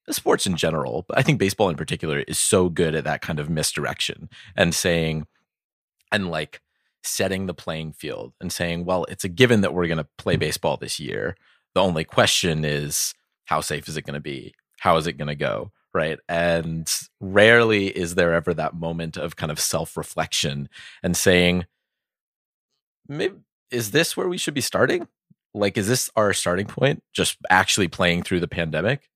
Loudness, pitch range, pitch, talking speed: -22 LUFS, 80-100 Hz, 90 Hz, 185 wpm